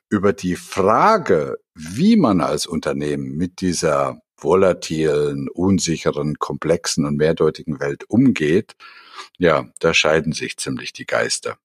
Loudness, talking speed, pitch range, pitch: -19 LUFS, 120 wpm, 75-100 Hz, 85 Hz